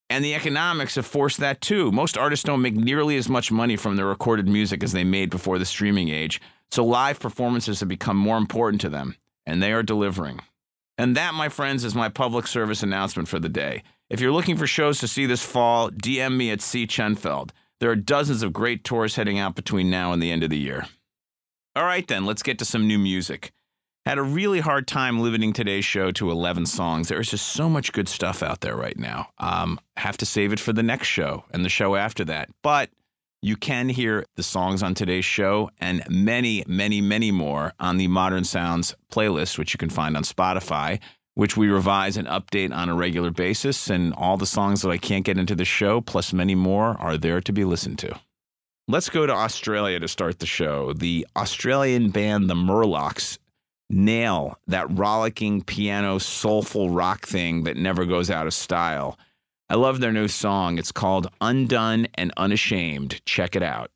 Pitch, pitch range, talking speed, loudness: 105 Hz, 90-120 Hz, 205 wpm, -23 LUFS